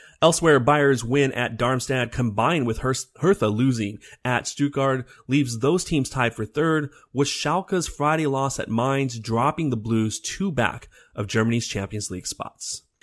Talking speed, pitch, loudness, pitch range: 155 wpm, 130 Hz, -23 LUFS, 115-145 Hz